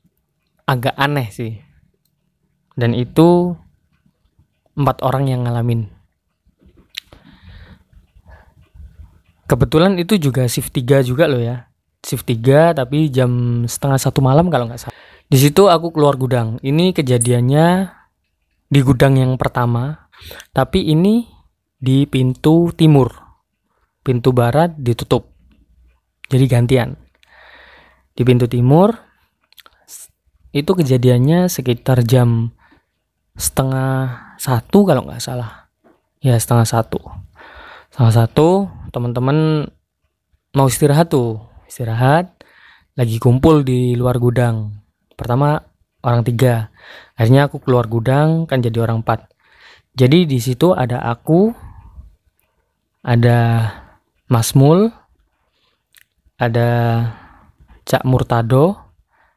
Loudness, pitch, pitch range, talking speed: -15 LUFS, 125 Hz, 115-145 Hz, 100 wpm